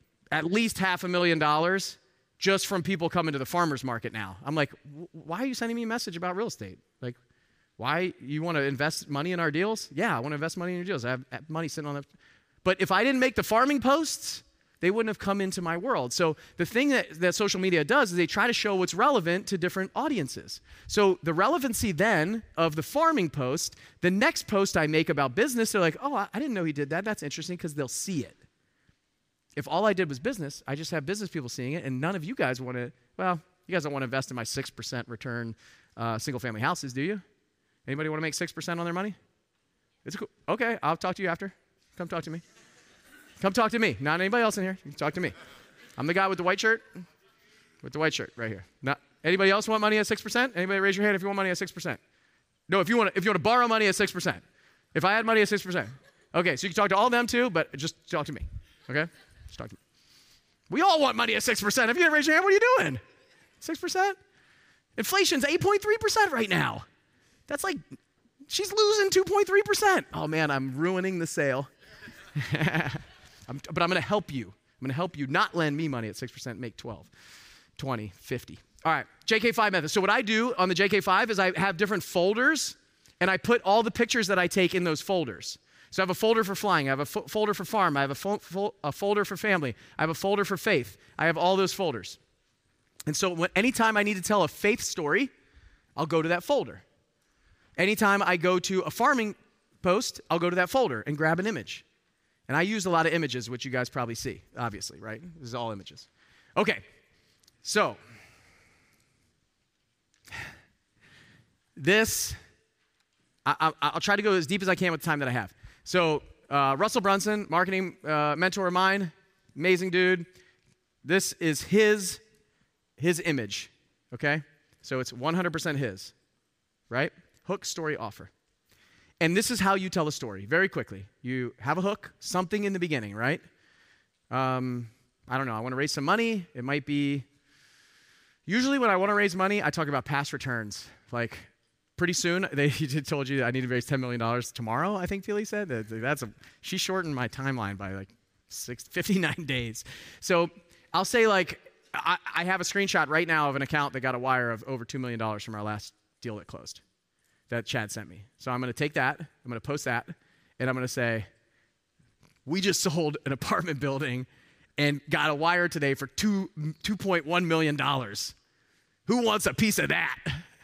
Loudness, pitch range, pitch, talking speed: -27 LUFS, 135-200 Hz, 170 Hz, 210 wpm